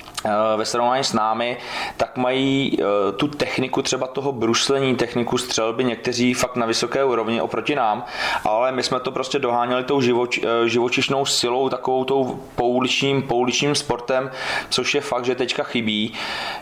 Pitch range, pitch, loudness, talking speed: 120-135 Hz, 125 Hz, -21 LUFS, 145 wpm